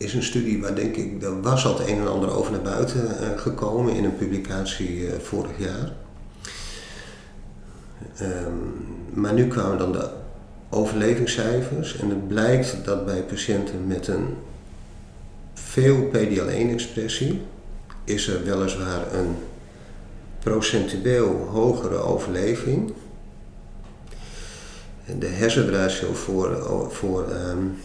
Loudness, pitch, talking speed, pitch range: -24 LUFS, 100 Hz, 110 wpm, 95-115 Hz